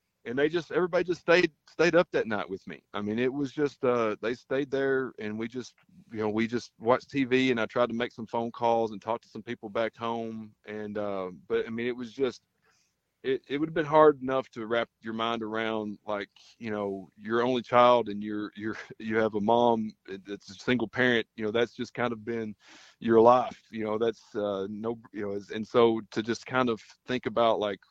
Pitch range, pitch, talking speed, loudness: 110-125 Hz, 115 Hz, 230 wpm, -28 LUFS